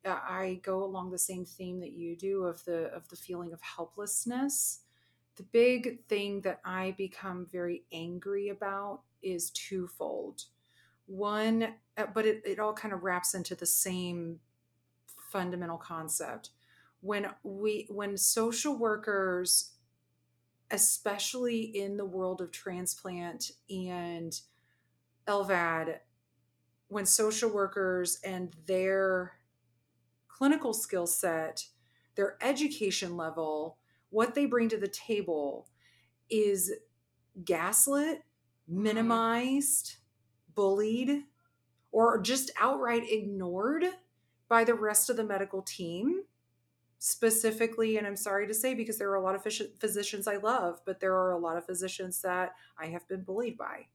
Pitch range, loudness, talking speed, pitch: 170-215 Hz, -32 LUFS, 125 wpm, 190 Hz